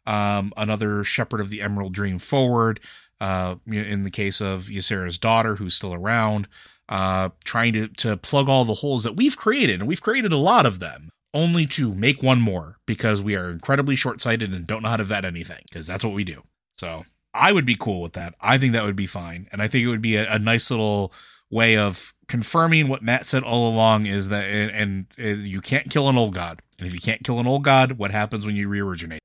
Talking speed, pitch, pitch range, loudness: 230 wpm, 110 Hz, 100-120 Hz, -22 LUFS